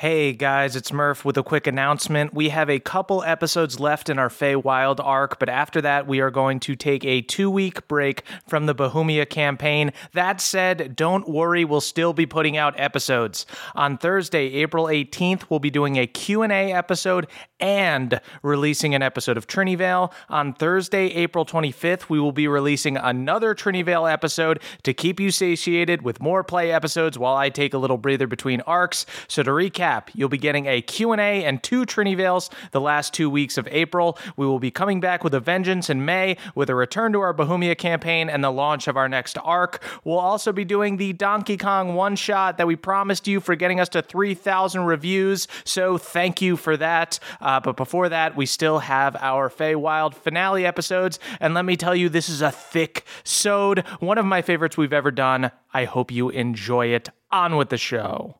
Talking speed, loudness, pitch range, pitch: 190 wpm, -21 LUFS, 140-180 Hz, 160 Hz